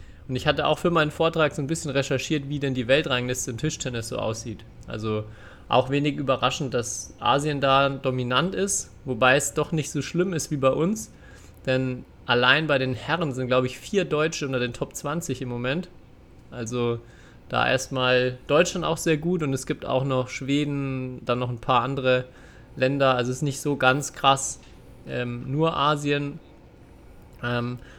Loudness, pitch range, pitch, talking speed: -24 LUFS, 125-150 Hz, 130 Hz, 180 wpm